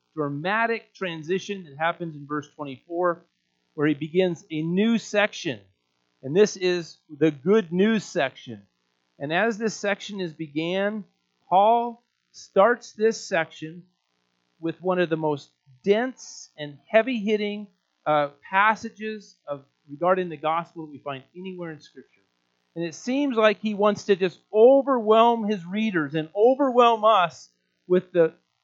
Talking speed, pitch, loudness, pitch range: 140 wpm, 175 Hz, -24 LUFS, 150-215 Hz